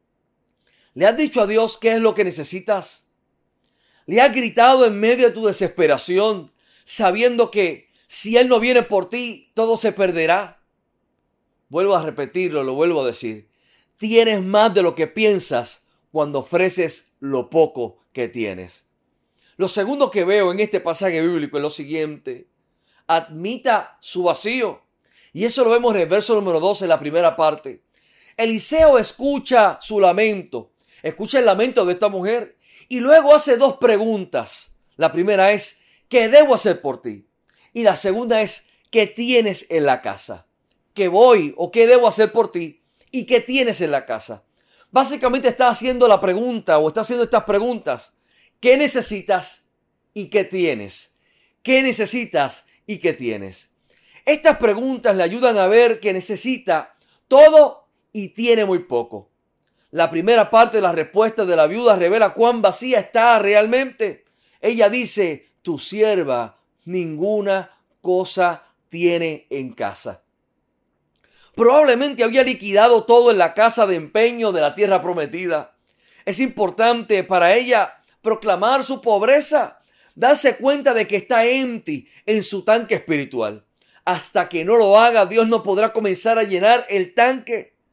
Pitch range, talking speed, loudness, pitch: 175-240 Hz, 150 wpm, -17 LUFS, 215 Hz